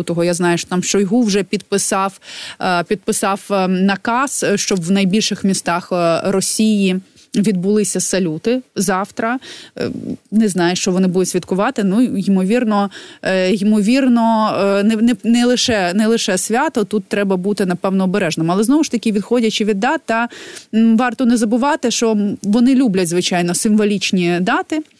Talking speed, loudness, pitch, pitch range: 135 wpm, -16 LUFS, 210 Hz, 190-235 Hz